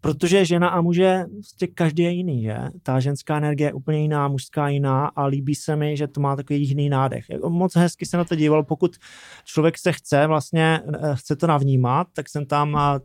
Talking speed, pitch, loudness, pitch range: 205 wpm, 150 Hz, -21 LUFS, 145-175 Hz